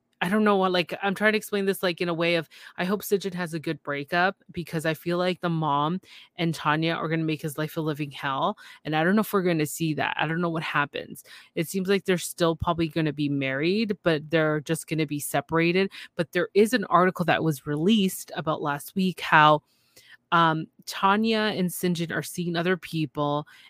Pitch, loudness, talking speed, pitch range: 170 Hz, -25 LUFS, 230 wpm, 155-185 Hz